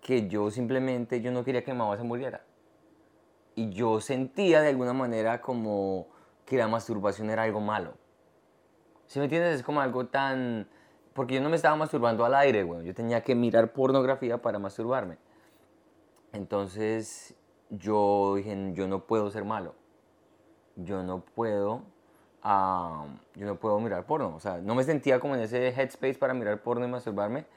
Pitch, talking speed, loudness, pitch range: 115 Hz, 170 wpm, -29 LUFS, 105-130 Hz